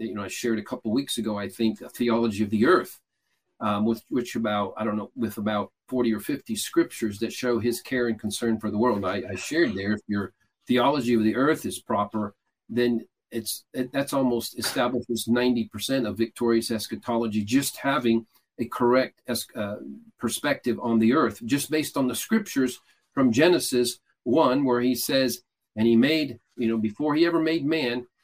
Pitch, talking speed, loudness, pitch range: 115 Hz, 195 wpm, -25 LUFS, 110-125 Hz